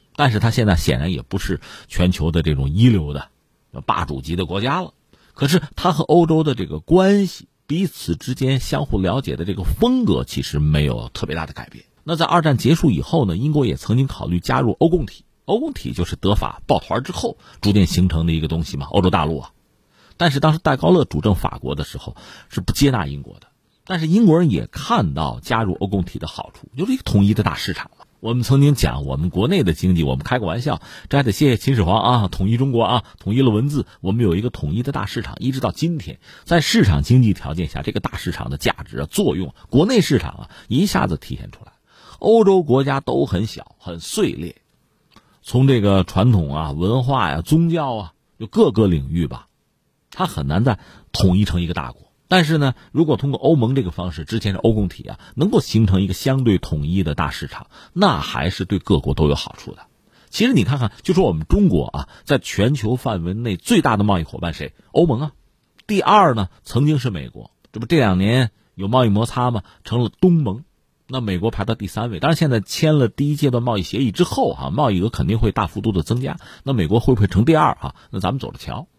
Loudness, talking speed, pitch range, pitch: -19 LUFS, 325 characters per minute, 90-135 Hz, 110 Hz